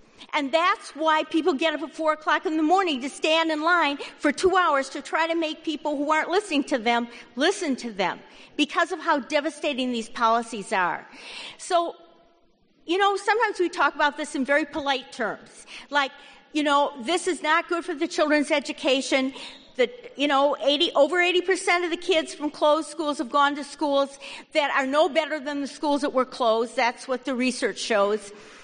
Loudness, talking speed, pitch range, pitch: -24 LUFS, 195 wpm, 275-330 Hz, 300 Hz